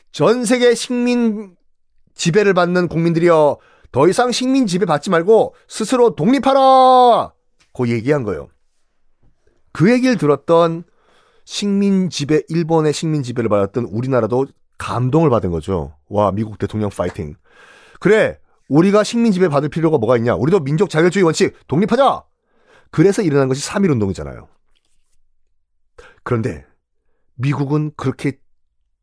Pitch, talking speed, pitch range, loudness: 160 Hz, 285 characters per minute, 125-205 Hz, -16 LUFS